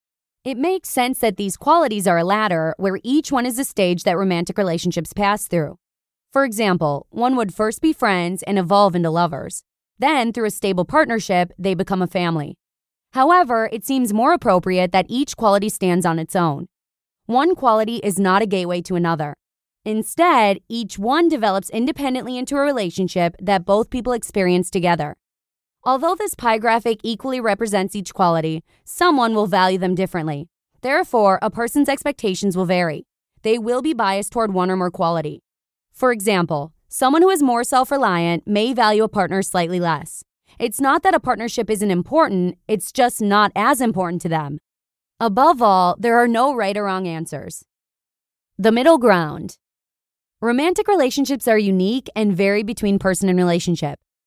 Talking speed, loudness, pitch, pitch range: 165 wpm, -19 LUFS, 205 Hz, 180-245 Hz